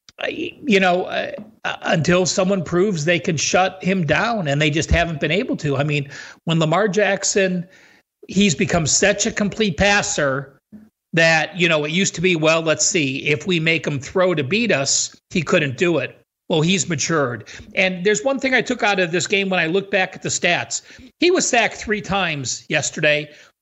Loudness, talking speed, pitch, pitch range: -18 LUFS, 195 wpm, 185 Hz, 155-200 Hz